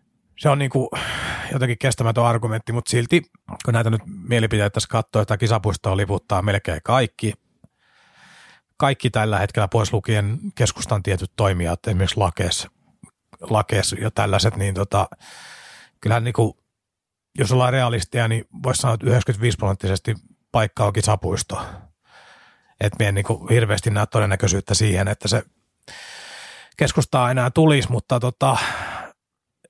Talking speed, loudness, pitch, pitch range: 125 wpm, -21 LUFS, 110 Hz, 100-120 Hz